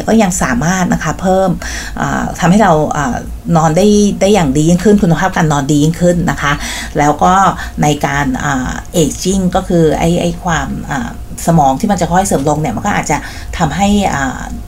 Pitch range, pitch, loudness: 160-190 Hz, 175 Hz, -12 LUFS